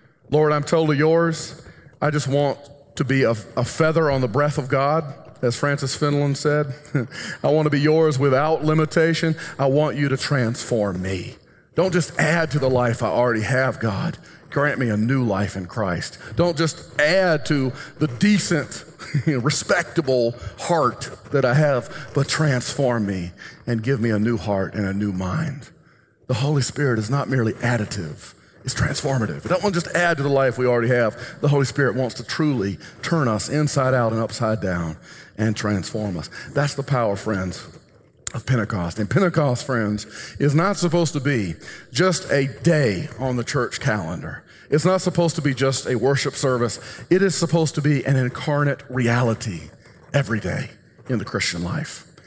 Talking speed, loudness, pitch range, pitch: 180 wpm, -21 LUFS, 115-155 Hz, 135 Hz